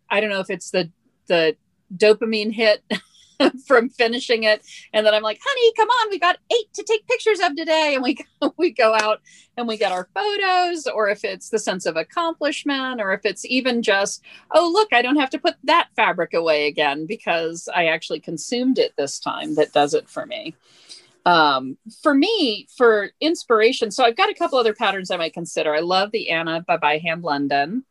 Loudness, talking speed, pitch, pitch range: -20 LUFS, 200 wpm, 225 Hz, 185-310 Hz